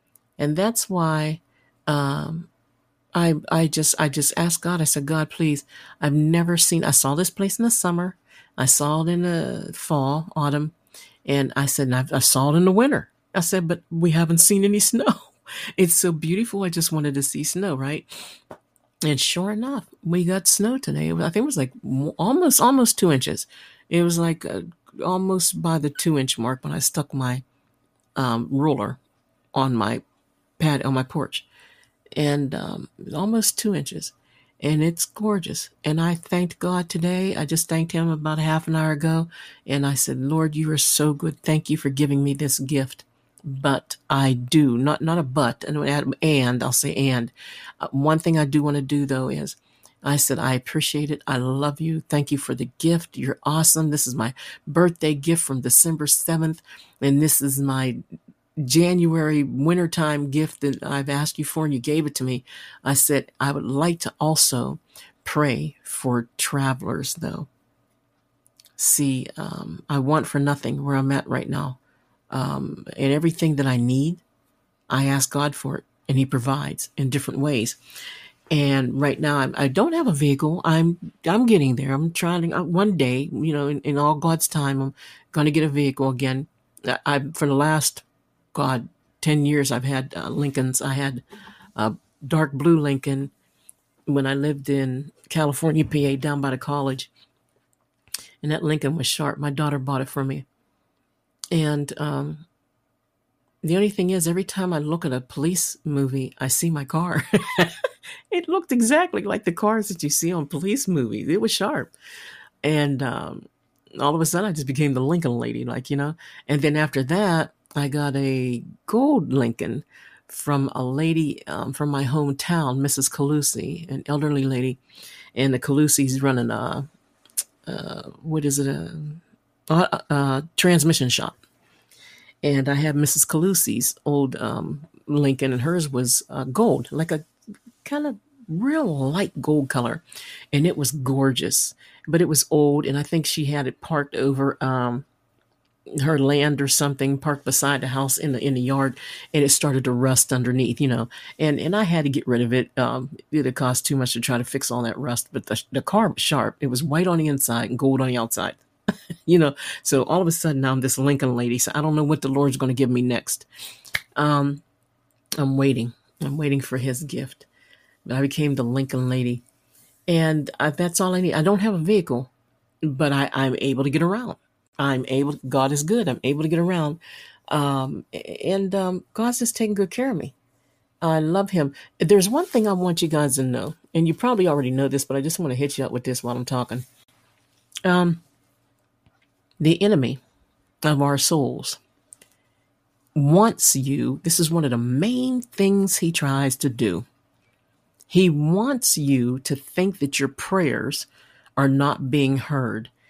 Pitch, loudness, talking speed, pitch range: 145 Hz, -22 LUFS, 185 wpm, 135-165 Hz